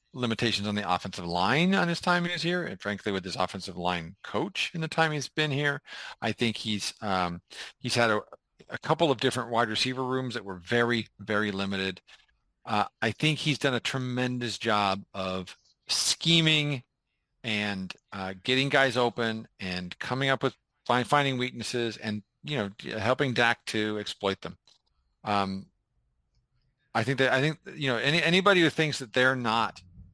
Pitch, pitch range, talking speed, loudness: 120 Hz, 100-135 Hz, 175 wpm, -28 LUFS